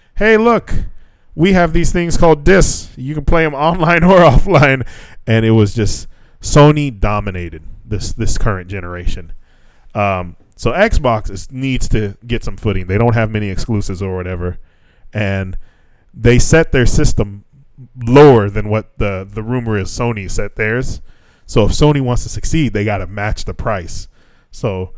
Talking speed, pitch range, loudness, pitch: 165 wpm, 100-135 Hz, -14 LUFS, 110 Hz